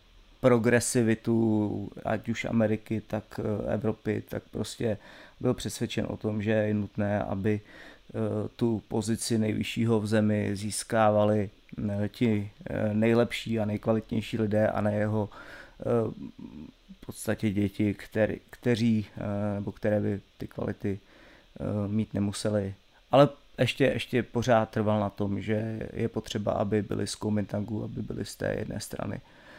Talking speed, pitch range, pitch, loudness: 125 wpm, 105-115 Hz, 110 Hz, -29 LUFS